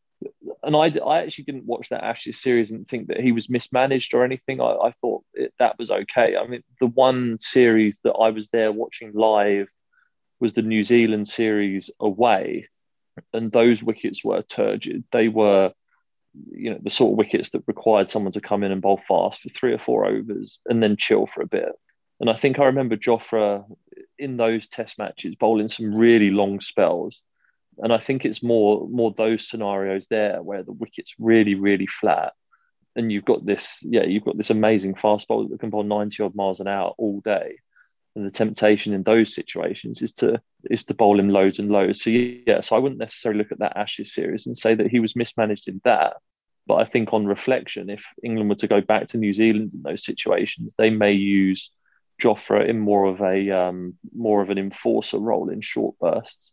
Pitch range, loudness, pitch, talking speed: 100-115 Hz, -21 LUFS, 110 Hz, 205 wpm